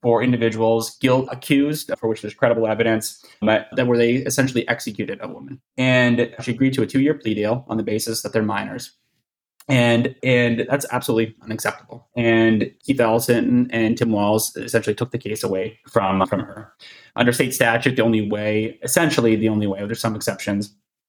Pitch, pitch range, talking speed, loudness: 115 Hz, 110-125 Hz, 180 wpm, -20 LUFS